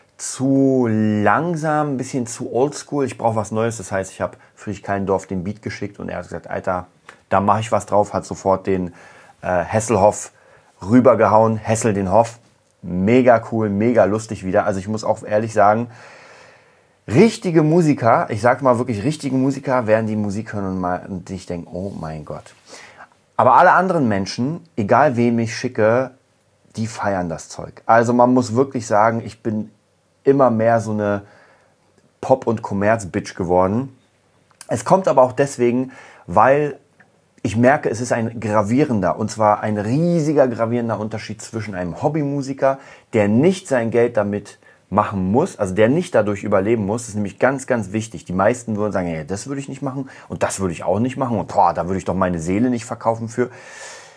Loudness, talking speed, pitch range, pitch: -19 LUFS, 180 wpm, 100-125 Hz, 110 Hz